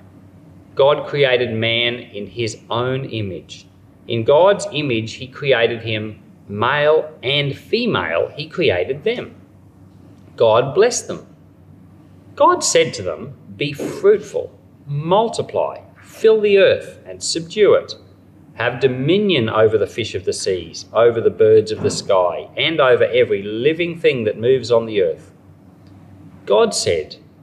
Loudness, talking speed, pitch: -17 LUFS, 135 wpm, 155 Hz